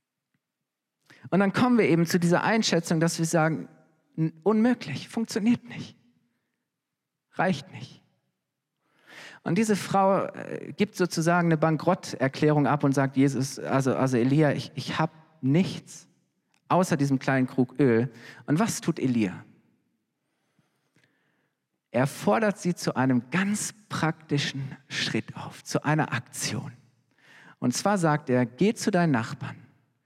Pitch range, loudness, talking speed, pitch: 135-175 Hz, -26 LUFS, 125 wpm, 155 Hz